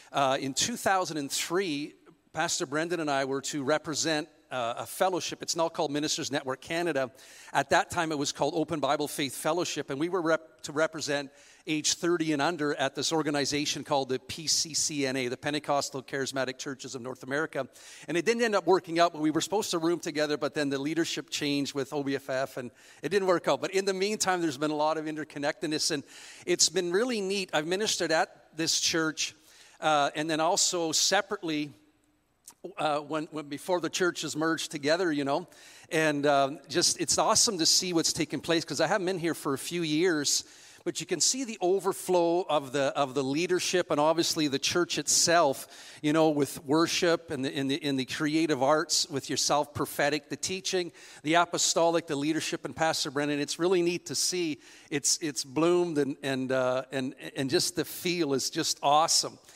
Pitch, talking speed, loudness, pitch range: 155 Hz, 195 wpm, -28 LUFS, 140-170 Hz